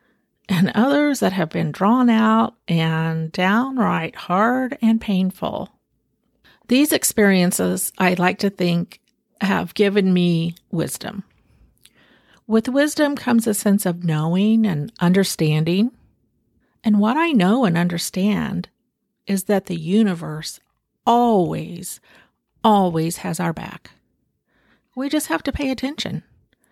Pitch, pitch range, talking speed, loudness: 200 Hz, 175-230 Hz, 115 wpm, -19 LUFS